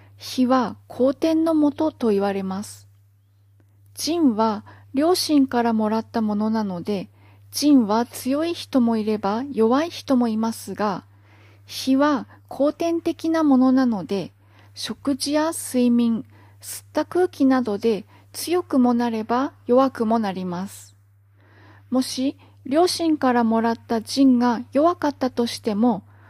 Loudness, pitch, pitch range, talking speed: -22 LUFS, 235 Hz, 185-275 Hz, 235 characters per minute